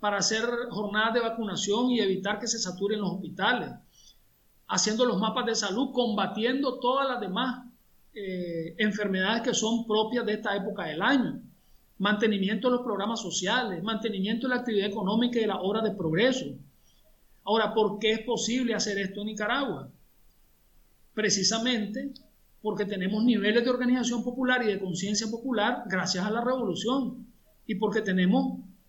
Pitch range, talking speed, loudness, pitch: 200-240 Hz, 155 wpm, -28 LUFS, 220 Hz